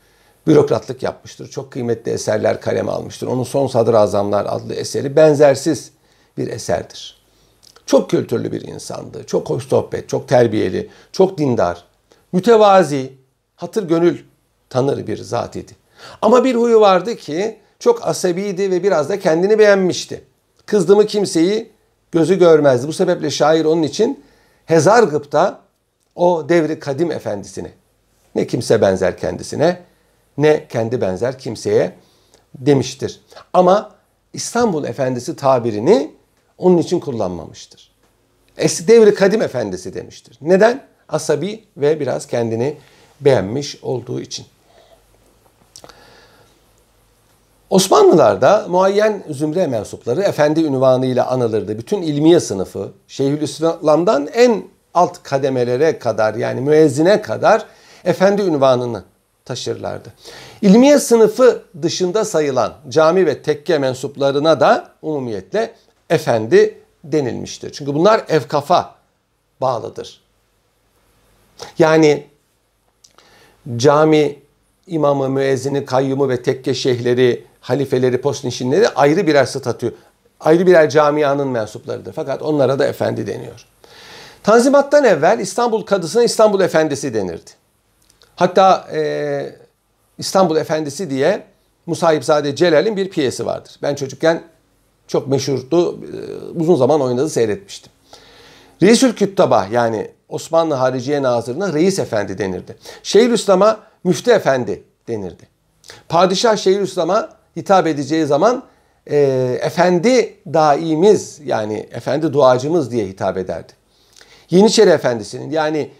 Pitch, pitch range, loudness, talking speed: 155 Hz, 130-190 Hz, -16 LUFS, 105 wpm